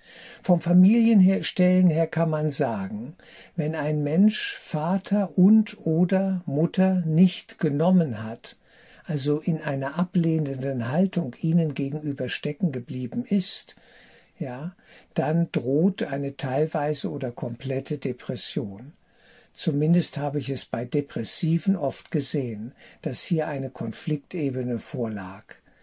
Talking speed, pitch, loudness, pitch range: 110 wpm, 155 Hz, -25 LUFS, 140-185 Hz